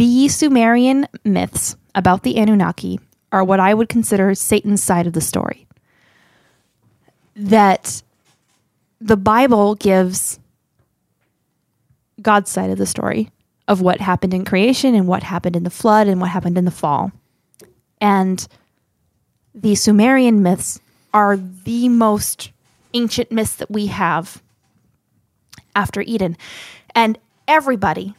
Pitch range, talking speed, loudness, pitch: 180-225 Hz, 125 wpm, -16 LUFS, 200 Hz